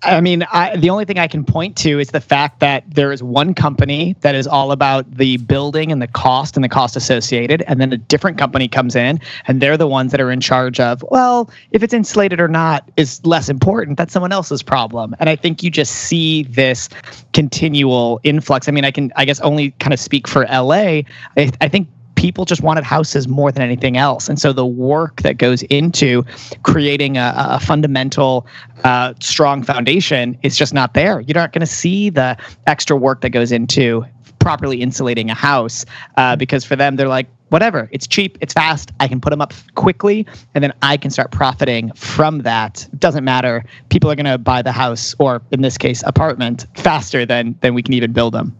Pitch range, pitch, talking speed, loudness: 125-155 Hz, 140 Hz, 210 wpm, -15 LUFS